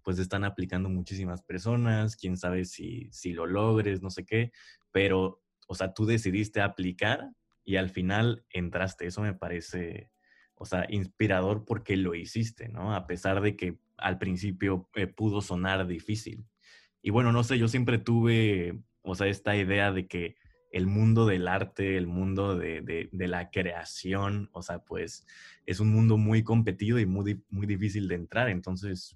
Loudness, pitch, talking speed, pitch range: -30 LUFS, 95 Hz, 170 wpm, 90-105 Hz